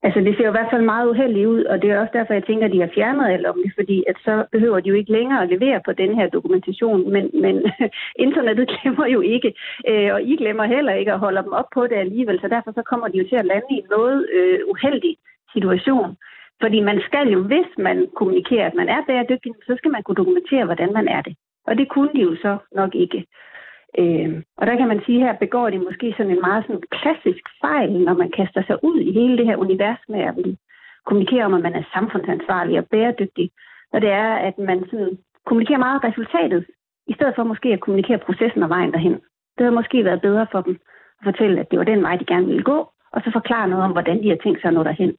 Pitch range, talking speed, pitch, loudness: 195-265 Hz, 250 wpm, 220 Hz, -19 LUFS